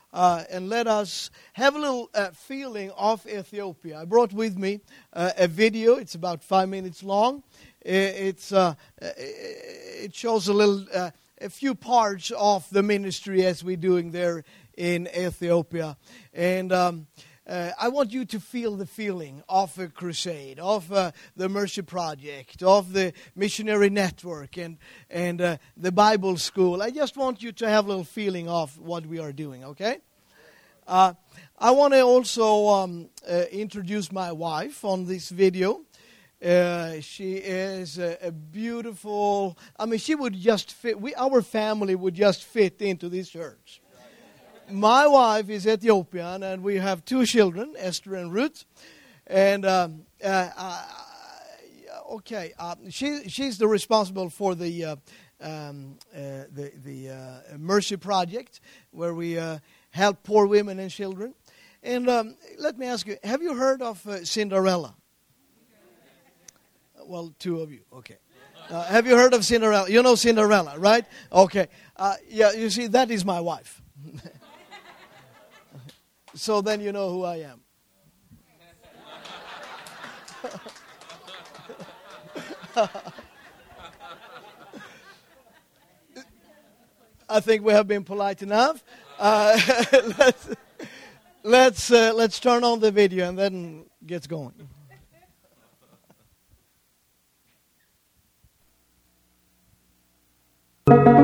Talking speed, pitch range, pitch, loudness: 130 wpm, 175-220 Hz, 195 Hz, -23 LUFS